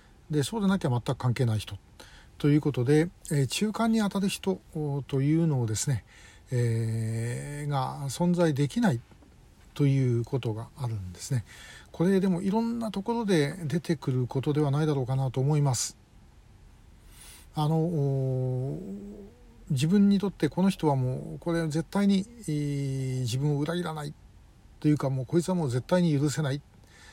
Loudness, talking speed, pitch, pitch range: -28 LUFS, 250 characters per minute, 145 Hz, 130-170 Hz